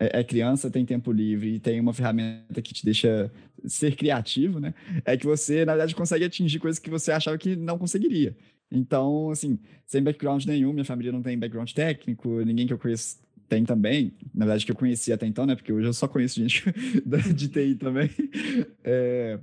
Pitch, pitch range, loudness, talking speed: 130 Hz, 115-155 Hz, -26 LUFS, 200 wpm